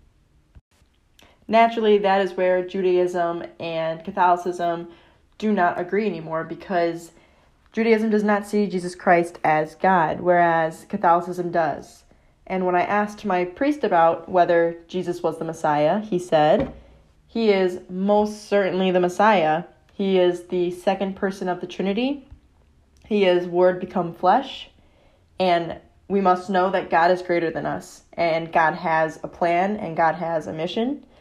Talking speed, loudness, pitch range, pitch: 145 wpm, -22 LUFS, 170-195 Hz, 180 Hz